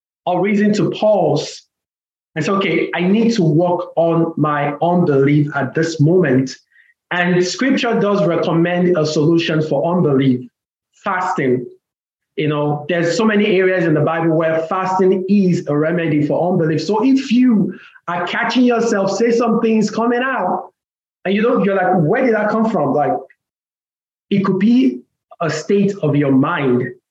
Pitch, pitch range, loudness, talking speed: 175 Hz, 155-205 Hz, -16 LUFS, 160 wpm